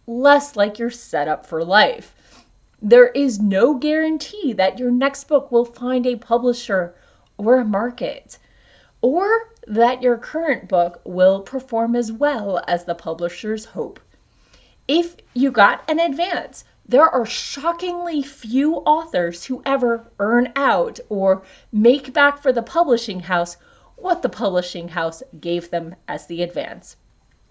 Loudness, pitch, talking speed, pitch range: -19 LUFS, 240 Hz, 140 wpm, 190-285 Hz